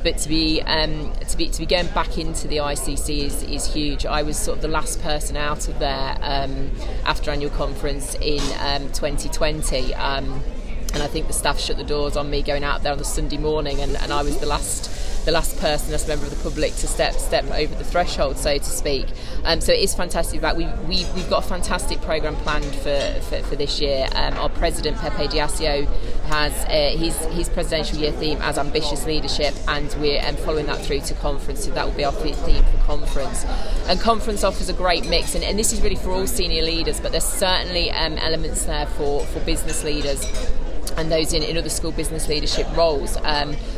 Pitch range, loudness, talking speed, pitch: 145-160 Hz, -23 LUFS, 220 wpm, 150 Hz